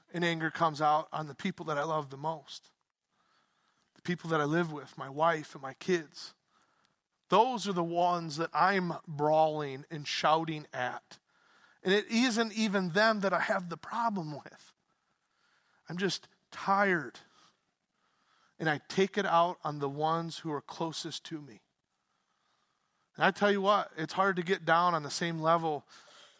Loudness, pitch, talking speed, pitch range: -31 LUFS, 165 Hz, 170 wpm, 155-195 Hz